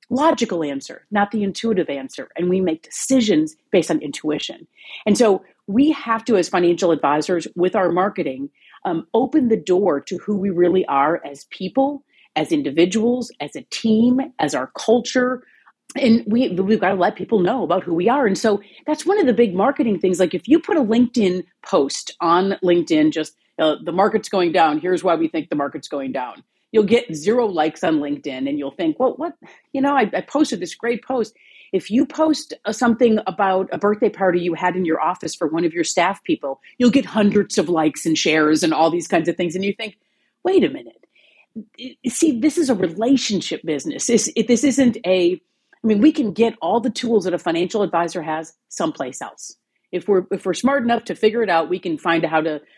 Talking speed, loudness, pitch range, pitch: 210 wpm, -19 LUFS, 175-245 Hz, 205 Hz